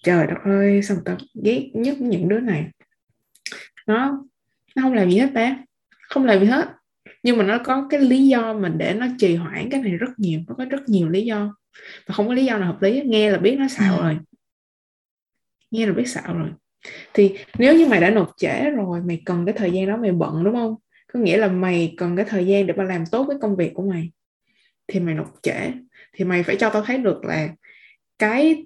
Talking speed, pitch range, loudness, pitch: 230 wpm, 185-250 Hz, -20 LUFS, 210 Hz